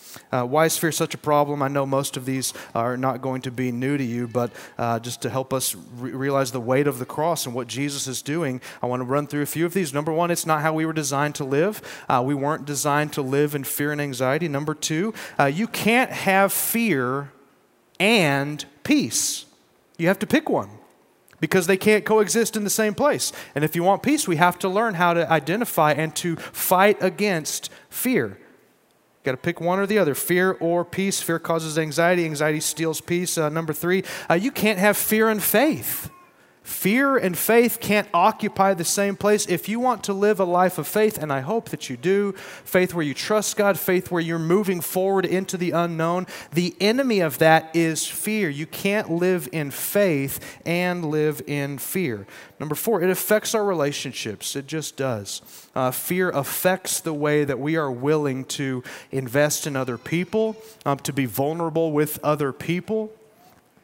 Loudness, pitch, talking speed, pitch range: -22 LUFS, 165 Hz, 200 wpm, 140-195 Hz